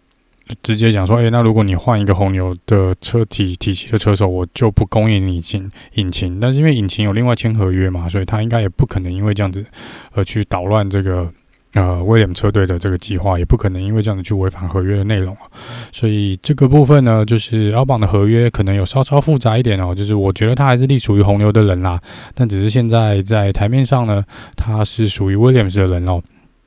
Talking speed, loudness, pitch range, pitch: 350 characters per minute, -15 LUFS, 95-115 Hz, 105 Hz